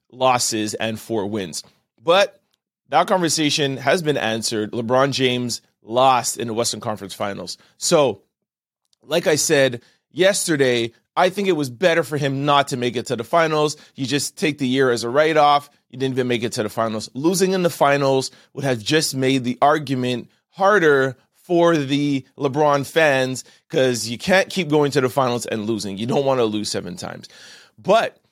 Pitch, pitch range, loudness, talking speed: 130 Hz, 120-150 Hz, -19 LUFS, 185 wpm